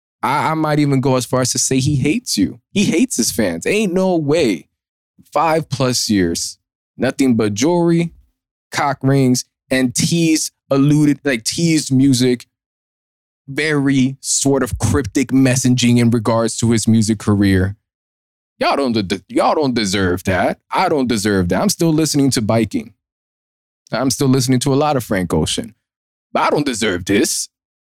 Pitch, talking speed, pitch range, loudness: 130 Hz, 160 wpm, 105-140 Hz, -16 LUFS